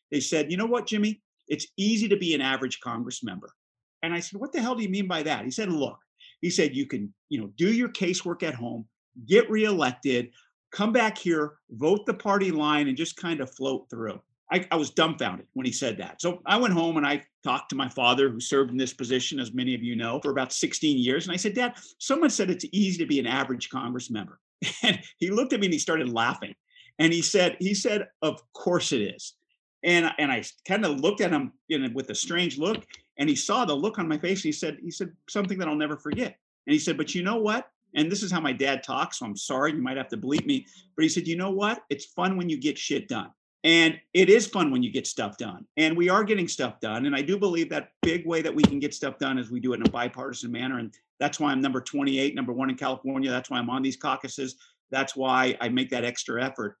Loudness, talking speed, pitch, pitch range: -26 LUFS, 260 wpm, 165 Hz, 135-200 Hz